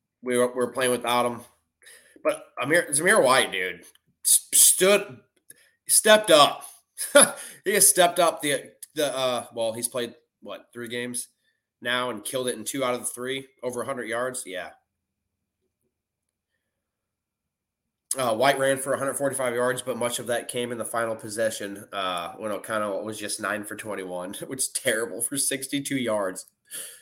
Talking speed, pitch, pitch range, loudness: 160 wpm, 125 Hz, 115-135 Hz, -23 LUFS